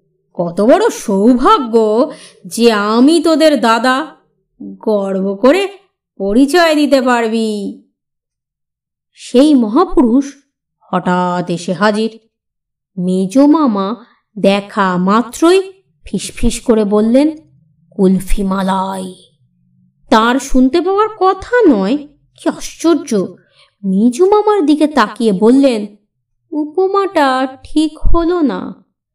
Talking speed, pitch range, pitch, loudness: 85 wpm, 195-305 Hz, 235 Hz, -13 LUFS